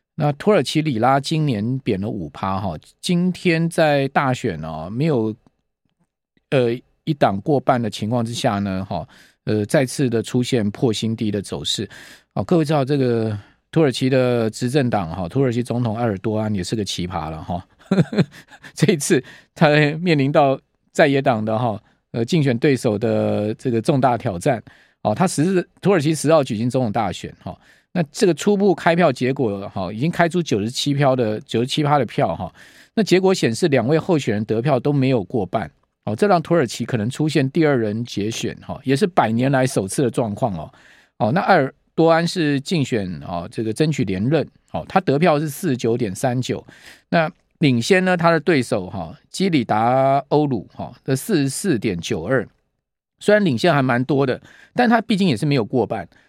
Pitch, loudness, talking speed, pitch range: 130 Hz, -20 LUFS, 275 characters per minute, 115-155 Hz